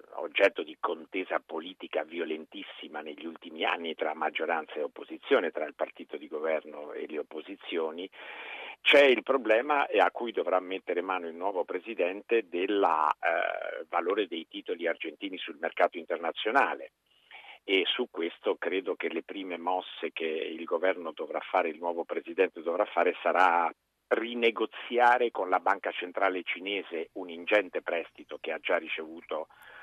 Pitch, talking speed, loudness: 385 Hz, 145 wpm, -30 LUFS